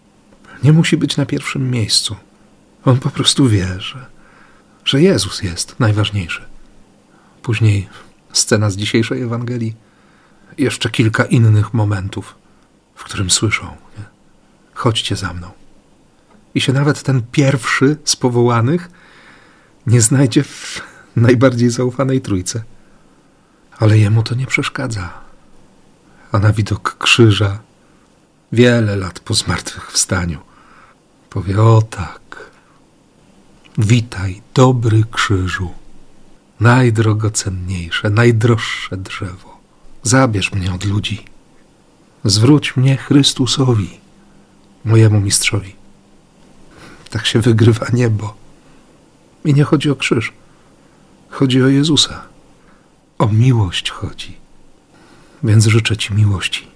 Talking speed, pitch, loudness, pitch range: 100 wpm, 115 Hz, -15 LUFS, 100-130 Hz